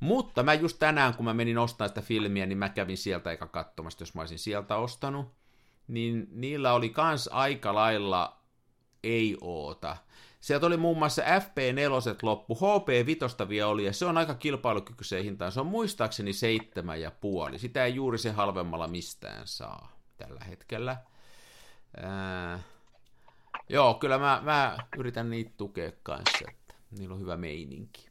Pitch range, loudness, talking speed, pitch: 100-135 Hz, -30 LUFS, 160 wpm, 115 Hz